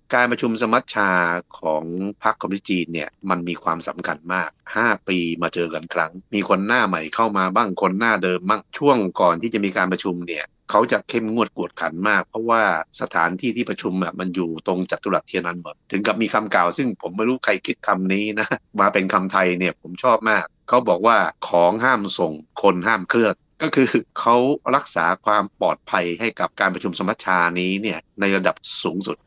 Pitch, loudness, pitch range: 95 Hz, -21 LUFS, 85-110 Hz